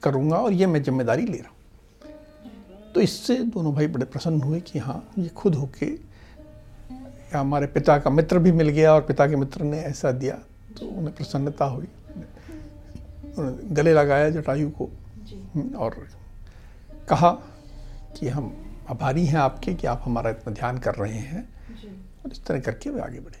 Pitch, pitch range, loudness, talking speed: 145 Hz, 120-165 Hz, -23 LUFS, 165 wpm